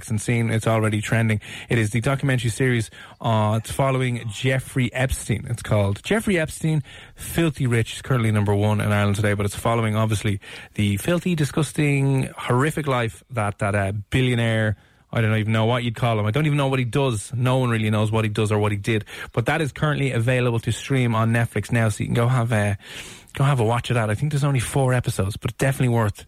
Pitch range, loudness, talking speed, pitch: 110-130 Hz, -22 LUFS, 225 wpm, 115 Hz